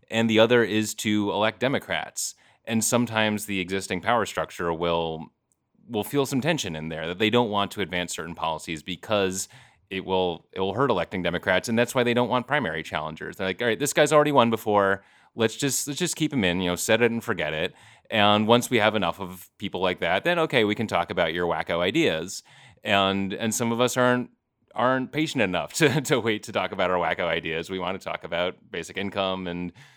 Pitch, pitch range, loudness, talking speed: 105 Hz, 95-120 Hz, -25 LUFS, 220 wpm